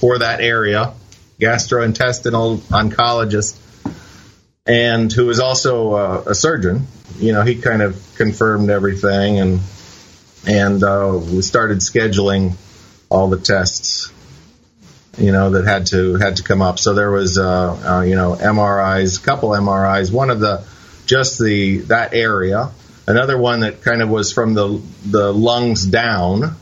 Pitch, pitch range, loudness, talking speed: 105 Hz, 95-115 Hz, -15 LUFS, 145 wpm